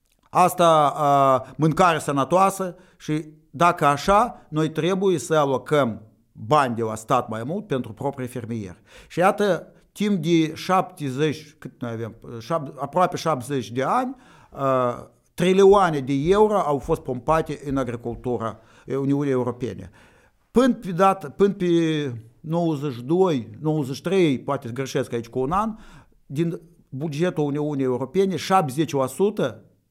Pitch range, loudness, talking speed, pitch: 130-180 Hz, -22 LUFS, 115 wpm, 150 Hz